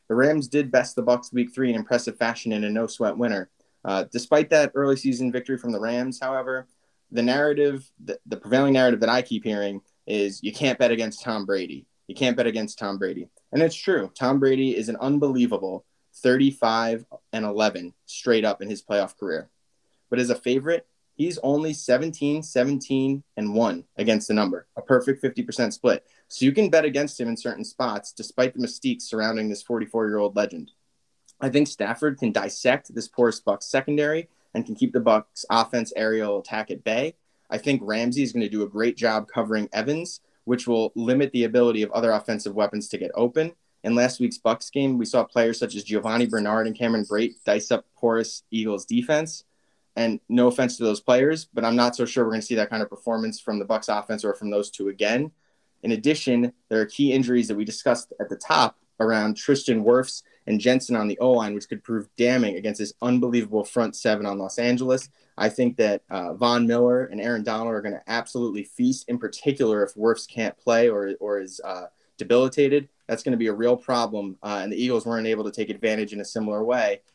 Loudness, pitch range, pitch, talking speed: -24 LUFS, 110-130 Hz, 120 Hz, 210 wpm